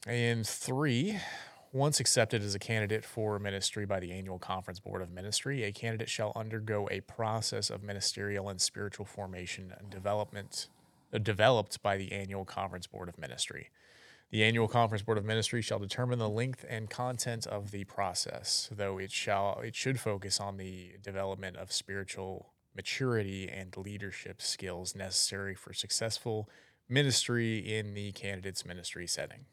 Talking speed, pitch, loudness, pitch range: 155 wpm, 100 Hz, -34 LUFS, 95-115 Hz